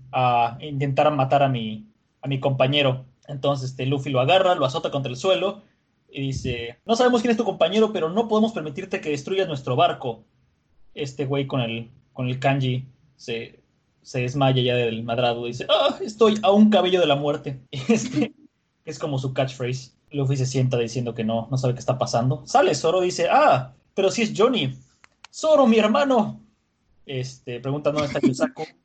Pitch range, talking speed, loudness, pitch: 125-180 Hz, 190 wpm, -22 LUFS, 140 Hz